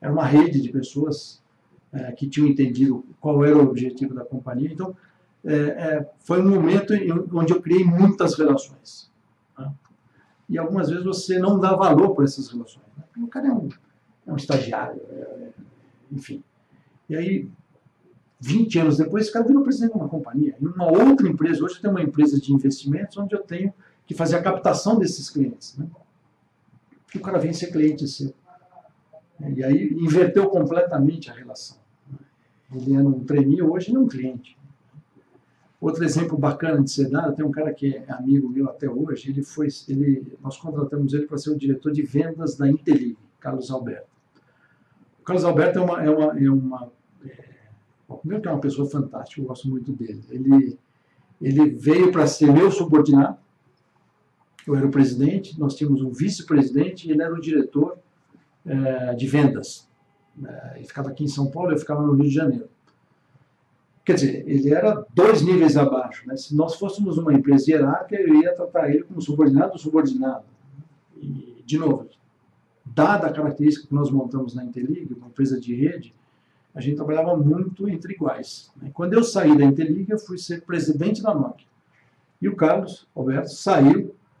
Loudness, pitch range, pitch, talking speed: -21 LUFS, 135-170 Hz, 150 Hz, 175 wpm